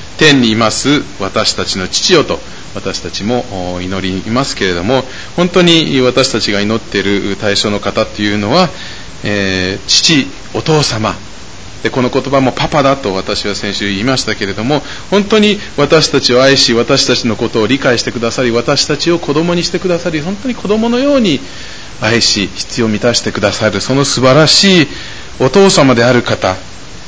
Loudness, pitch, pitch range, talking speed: -11 LUFS, 120 Hz, 100-145 Hz, 325 characters per minute